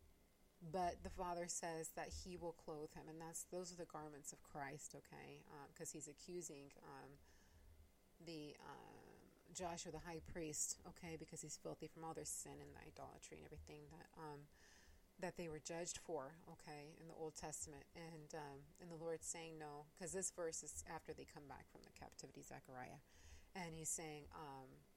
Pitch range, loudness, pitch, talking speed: 145-170 Hz, -52 LUFS, 160 Hz, 185 wpm